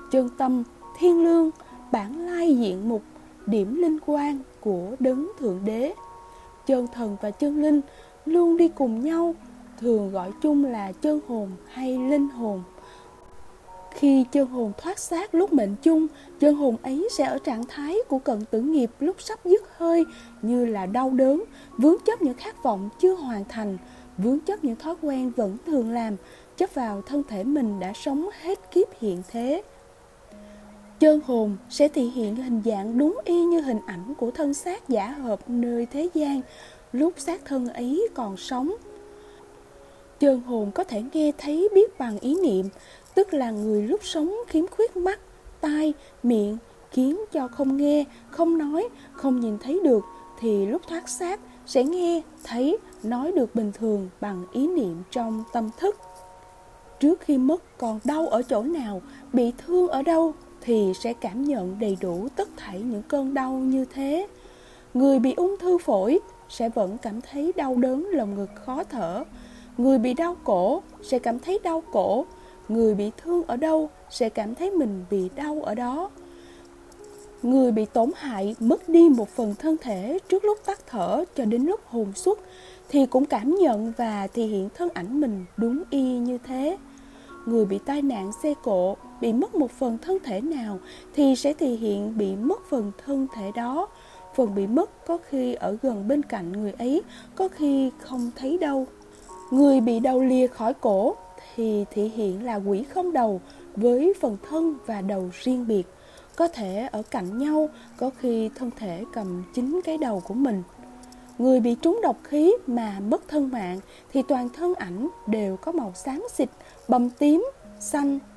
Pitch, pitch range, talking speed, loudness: 260 Hz, 225-315 Hz, 175 wpm, -25 LUFS